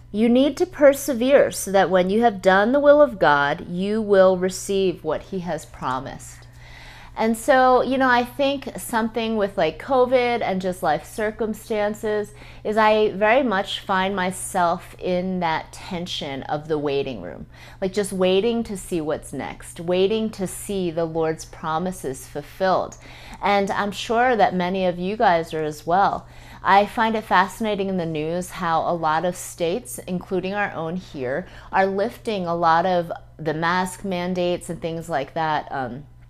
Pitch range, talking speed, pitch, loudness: 165-215 Hz, 170 wpm, 185 Hz, -21 LUFS